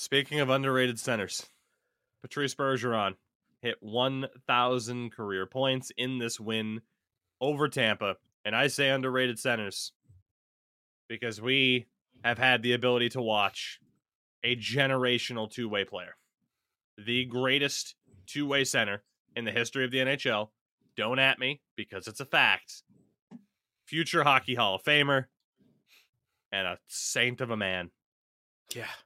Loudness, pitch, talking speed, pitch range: -29 LUFS, 125 Hz, 130 wpm, 115-135 Hz